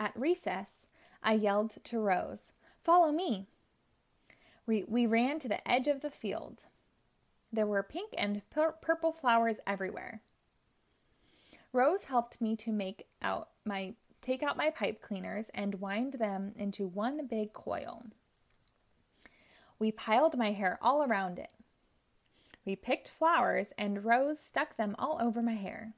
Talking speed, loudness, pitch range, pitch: 145 wpm, -33 LUFS, 205-275 Hz, 225 Hz